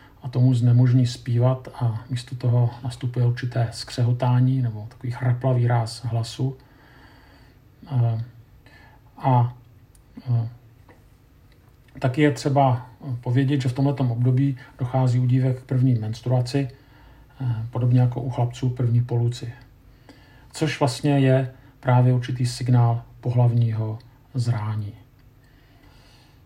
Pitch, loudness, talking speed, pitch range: 125 Hz, -23 LUFS, 100 wpm, 120-130 Hz